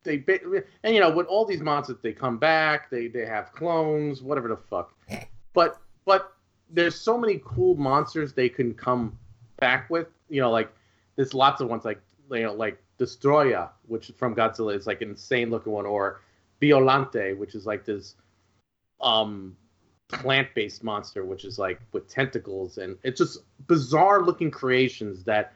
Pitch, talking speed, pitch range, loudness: 125 Hz, 170 wpm, 105-155 Hz, -25 LUFS